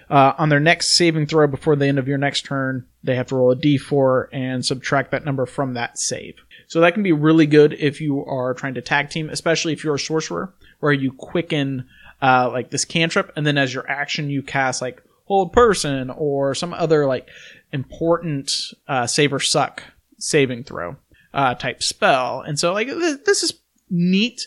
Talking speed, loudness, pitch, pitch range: 200 wpm, -19 LUFS, 145 Hz, 135-165 Hz